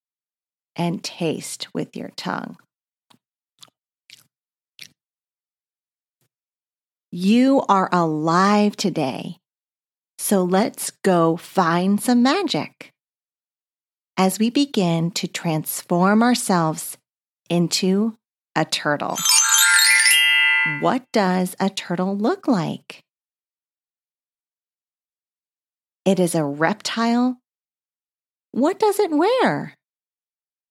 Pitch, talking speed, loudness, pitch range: 195 Hz, 75 wpm, -19 LUFS, 170-230 Hz